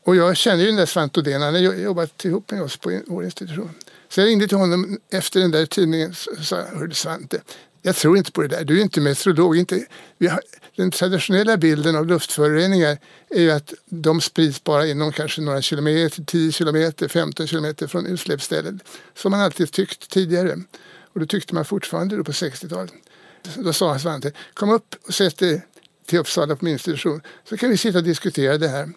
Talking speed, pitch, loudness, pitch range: 200 wpm, 170 Hz, -20 LUFS, 155-185 Hz